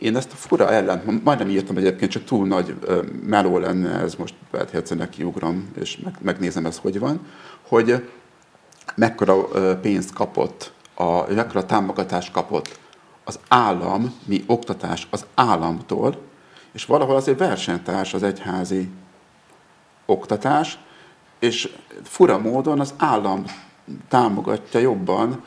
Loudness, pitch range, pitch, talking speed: -21 LUFS, 95-120 Hz, 100 Hz, 125 wpm